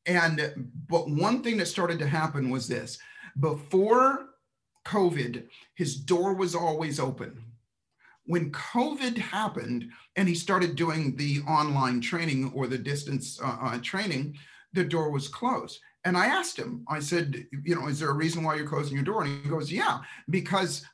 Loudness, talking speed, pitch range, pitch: -28 LUFS, 165 wpm, 140-185 Hz, 160 Hz